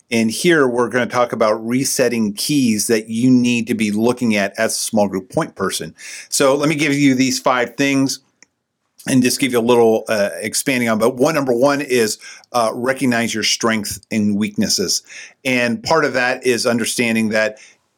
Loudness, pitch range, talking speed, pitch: -17 LUFS, 110-130 Hz, 185 wpm, 120 Hz